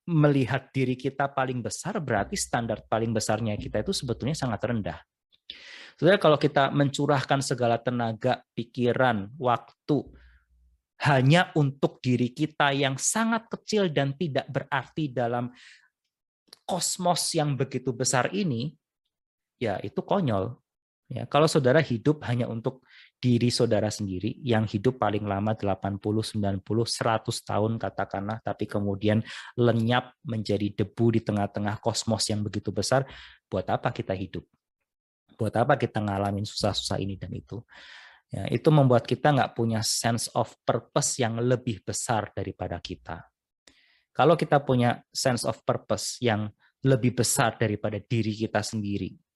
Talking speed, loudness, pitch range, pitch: 130 wpm, -27 LUFS, 105-135 Hz, 120 Hz